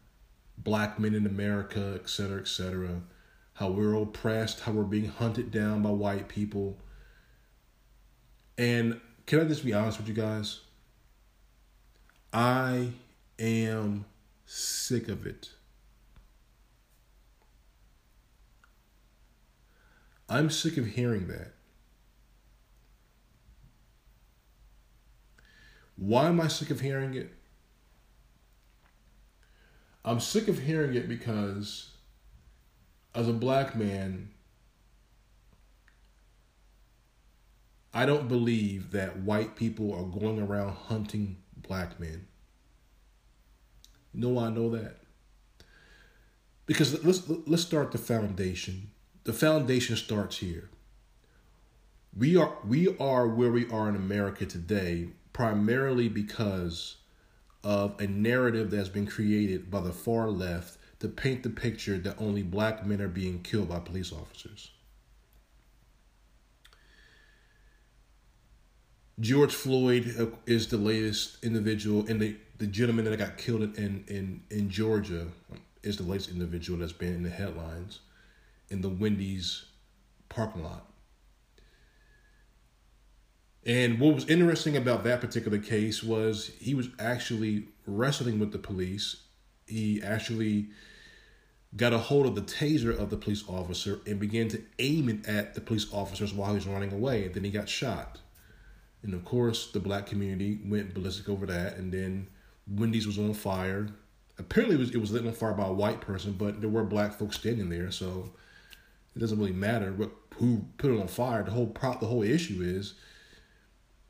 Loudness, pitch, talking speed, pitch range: -31 LUFS, 105 Hz, 130 wpm, 100-115 Hz